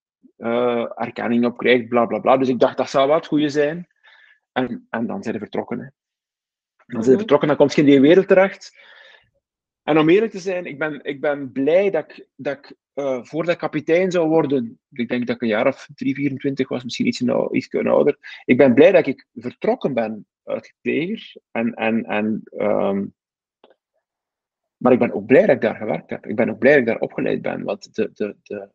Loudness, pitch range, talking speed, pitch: -19 LUFS, 120-165 Hz, 220 wpm, 140 Hz